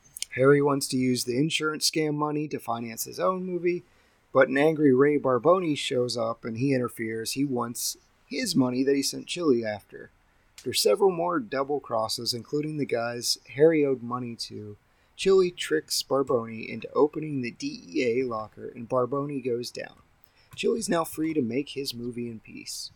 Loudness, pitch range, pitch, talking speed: -26 LUFS, 120-150 Hz, 135 Hz, 170 wpm